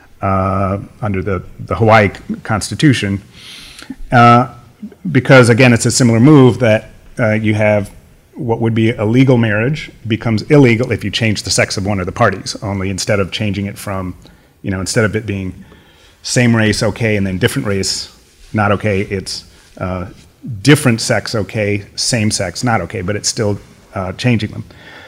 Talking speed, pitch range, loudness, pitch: 170 wpm, 95-120 Hz, -14 LUFS, 105 Hz